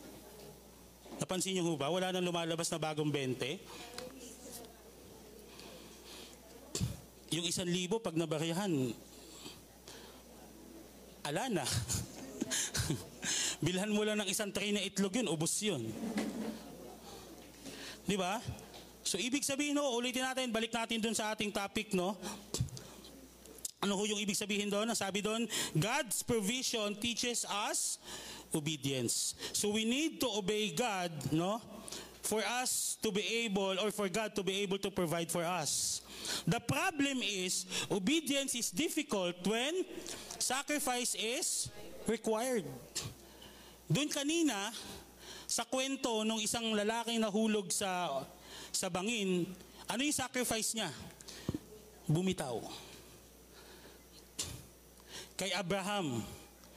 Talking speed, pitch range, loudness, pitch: 115 wpm, 185-235 Hz, -35 LUFS, 210 Hz